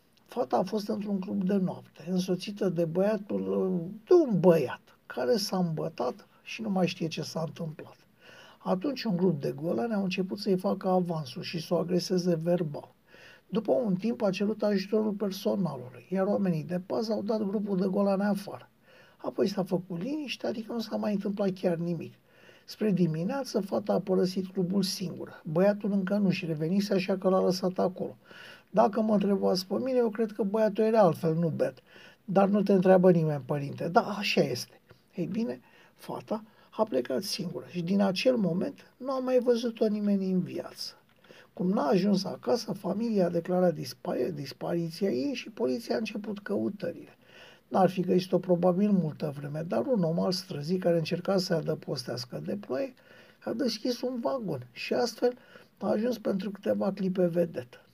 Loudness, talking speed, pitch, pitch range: -29 LUFS, 170 wpm, 190 Hz, 175-210 Hz